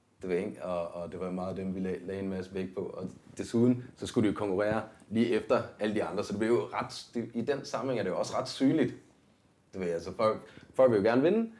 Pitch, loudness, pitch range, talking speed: 100 Hz, -31 LUFS, 95-115 Hz, 260 wpm